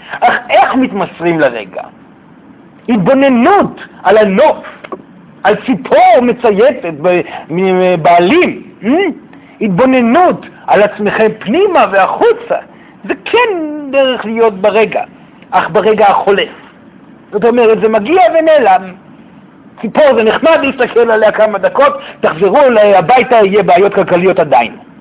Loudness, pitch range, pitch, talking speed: -9 LUFS, 200-275 Hz, 225 Hz, 105 wpm